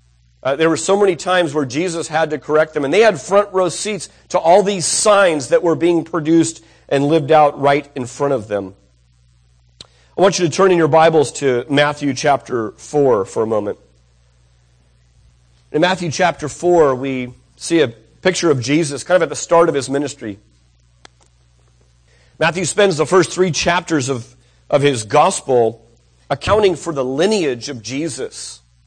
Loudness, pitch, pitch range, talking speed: -16 LUFS, 145 Hz, 105-170 Hz, 175 wpm